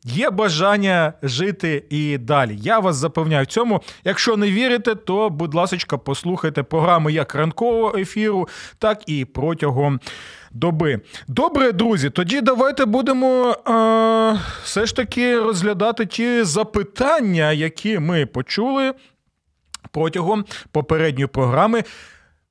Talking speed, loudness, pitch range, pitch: 115 wpm, -19 LUFS, 155-225 Hz, 190 Hz